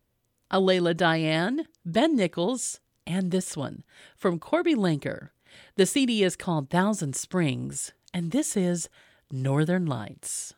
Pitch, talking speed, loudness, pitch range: 180 Hz, 120 wpm, -26 LUFS, 160-195 Hz